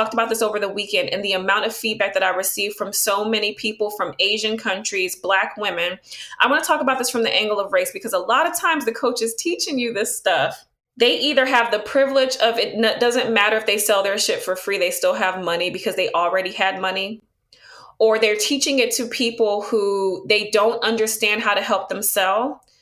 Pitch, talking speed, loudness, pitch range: 215 Hz, 225 wpm, -19 LUFS, 195-230 Hz